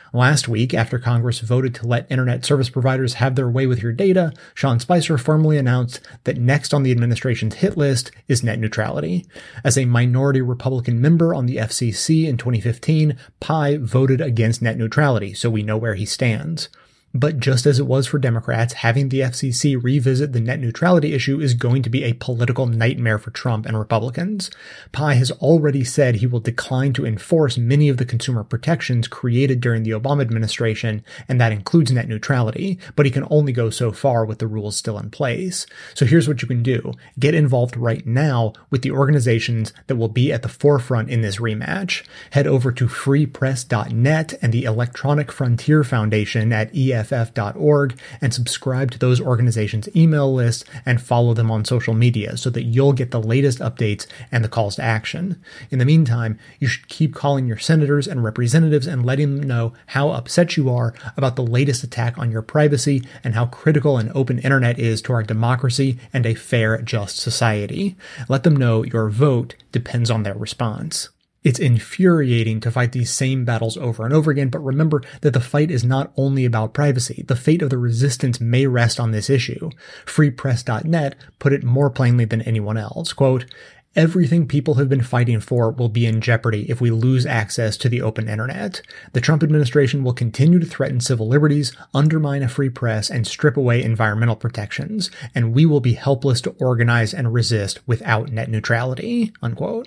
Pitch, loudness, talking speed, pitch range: 125 Hz, -19 LUFS, 185 wpm, 115-140 Hz